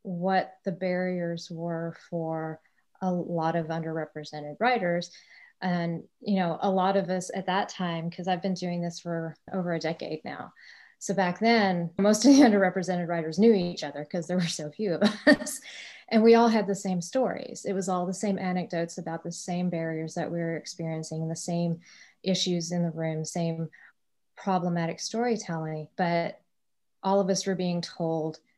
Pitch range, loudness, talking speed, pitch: 165-195 Hz, -28 LUFS, 180 wpm, 180 Hz